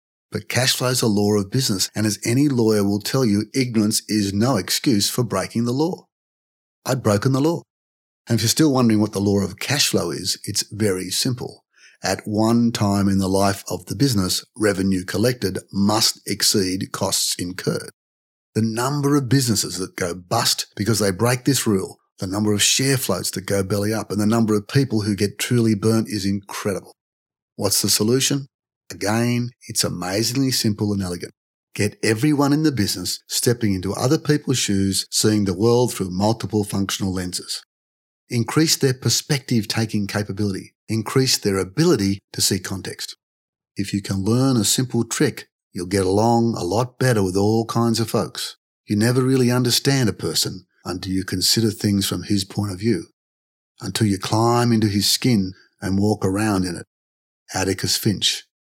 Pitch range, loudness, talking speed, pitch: 95-120 Hz, -20 LUFS, 175 wpm, 105 Hz